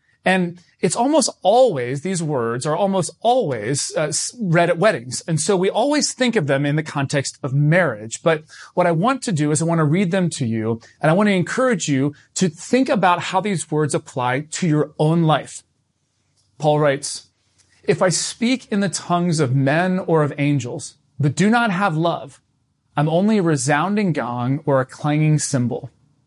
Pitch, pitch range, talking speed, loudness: 160 Hz, 140-190 Hz, 190 wpm, -19 LUFS